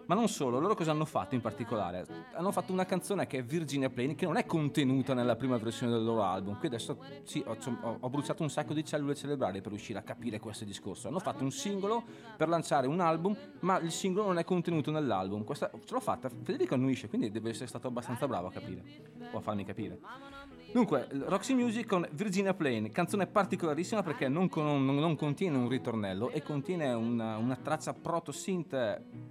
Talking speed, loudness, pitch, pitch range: 200 wpm, -34 LUFS, 145 Hz, 120-180 Hz